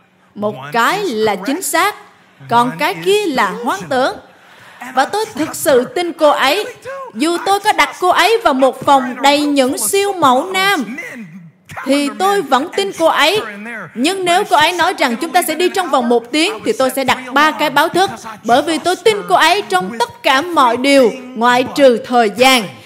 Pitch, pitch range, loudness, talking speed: 285 Hz, 245-360 Hz, -13 LUFS, 195 wpm